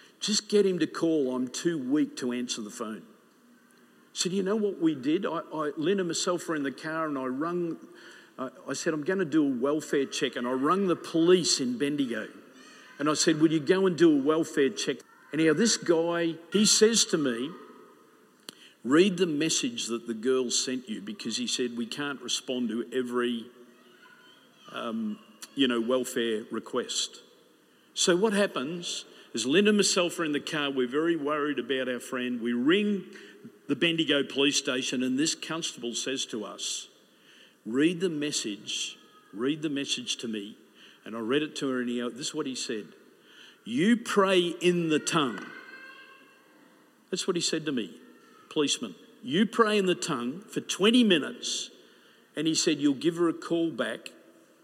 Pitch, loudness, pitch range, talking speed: 165 Hz, -28 LUFS, 130-210 Hz, 185 wpm